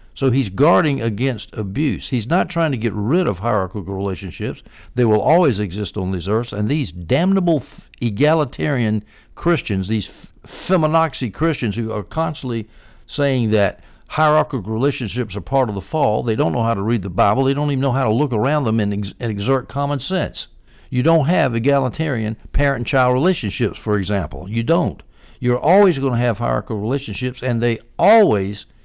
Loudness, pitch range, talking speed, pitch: -19 LUFS, 105-140 Hz, 180 wpm, 120 Hz